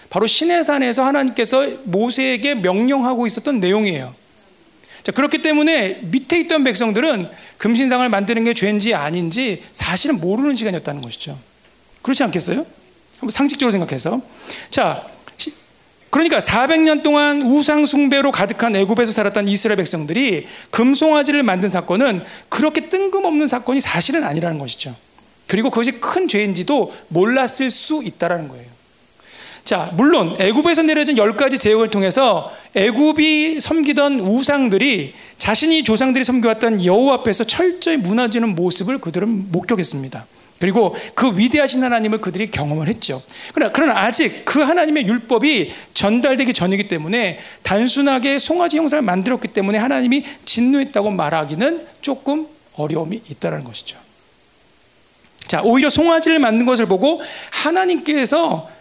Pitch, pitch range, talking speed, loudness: 250 Hz, 200-290 Hz, 350 characters per minute, -16 LUFS